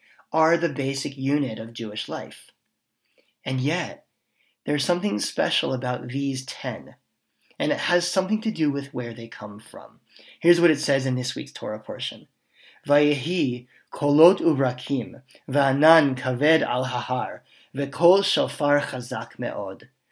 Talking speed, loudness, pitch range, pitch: 135 wpm, -23 LUFS, 125-160 Hz, 140 Hz